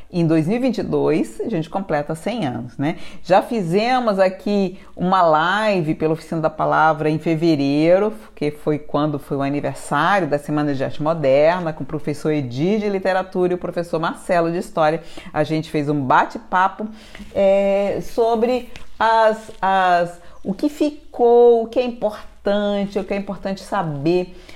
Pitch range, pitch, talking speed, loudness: 155-205 Hz, 180 Hz, 155 wpm, -19 LUFS